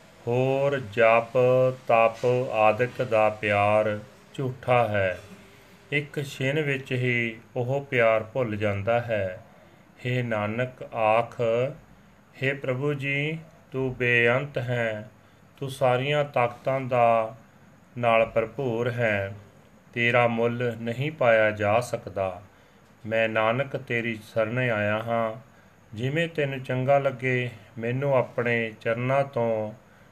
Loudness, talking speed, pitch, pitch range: -25 LUFS, 105 wpm, 120 Hz, 110-130 Hz